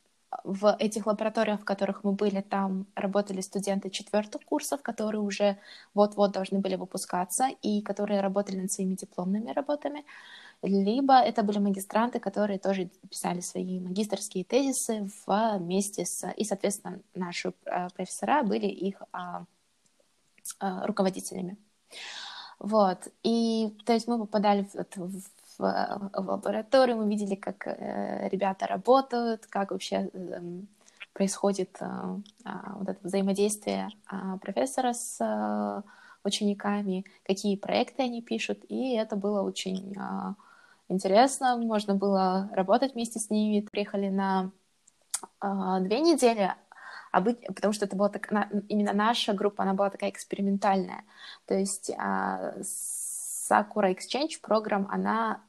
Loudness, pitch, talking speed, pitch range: -29 LUFS, 200 Hz, 110 wpm, 195-215 Hz